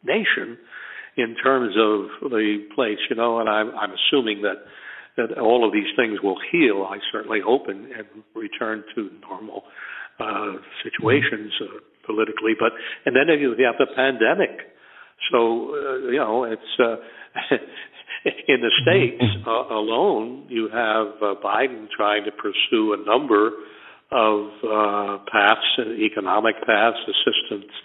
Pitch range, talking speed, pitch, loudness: 105-120 Hz, 140 wpm, 110 Hz, -21 LUFS